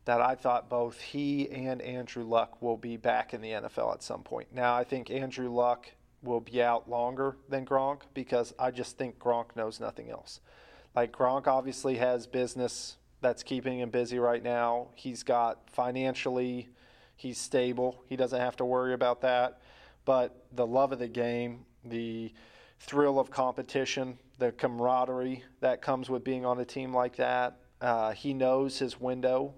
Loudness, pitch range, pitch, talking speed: -32 LUFS, 120-130 Hz, 125 Hz, 170 wpm